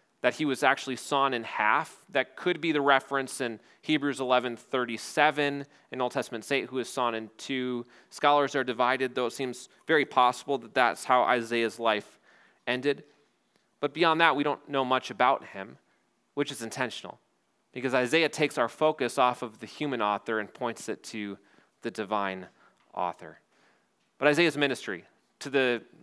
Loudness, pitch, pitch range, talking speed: -28 LUFS, 130 Hz, 120-145 Hz, 170 wpm